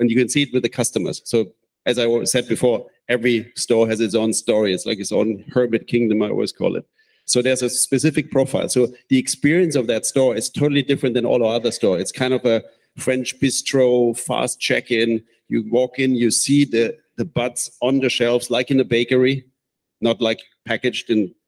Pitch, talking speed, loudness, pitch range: 125 Hz, 210 wpm, -19 LUFS, 115-130 Hz